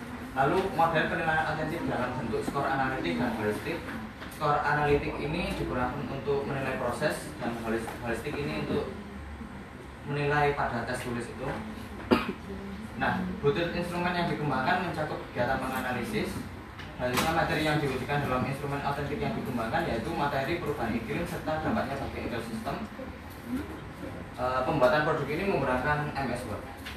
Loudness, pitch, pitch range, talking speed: -30 LUFS, 145 Hz, 125-155 Hz, 130 wpm